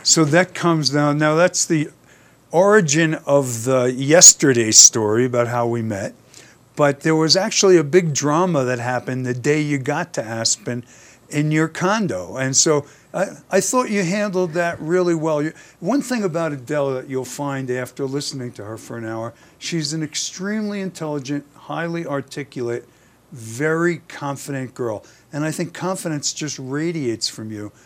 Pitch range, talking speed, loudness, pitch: 130-170 Hz, 165 wpm, -18 LUFS, 145 Hz